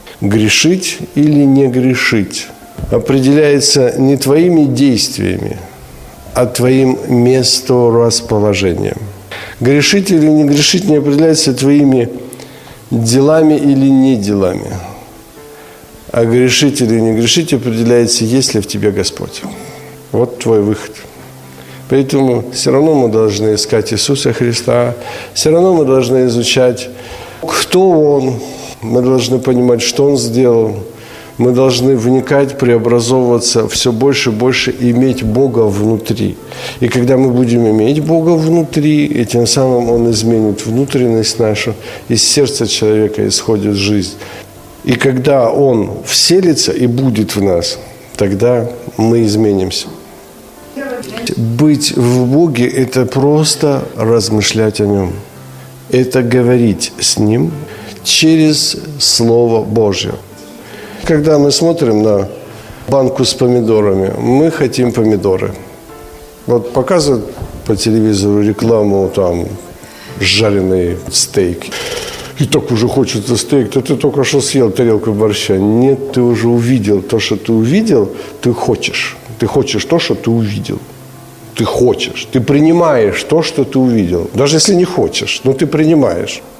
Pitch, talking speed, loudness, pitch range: 120 Hz, 120 wpm, -11 LUFS, 110-135 Hz